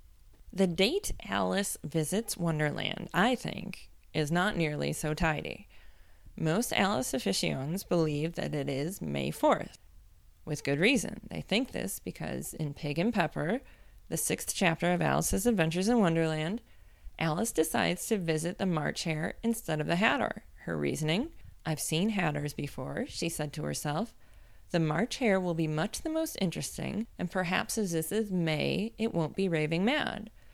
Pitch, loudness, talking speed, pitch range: 170 Hz, -31 LUFS, 160 wpm, 155-210 Hz